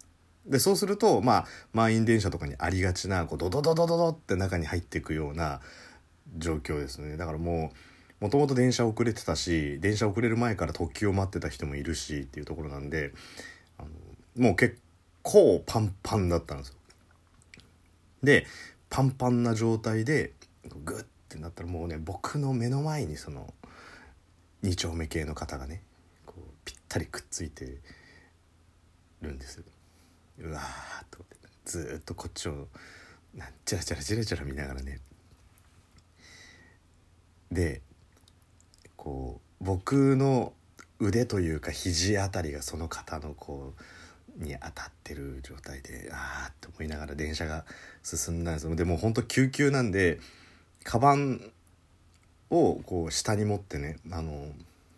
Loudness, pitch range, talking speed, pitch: -29 LUFS, 80-100 Hz, 275 characters per minute, 85 Hz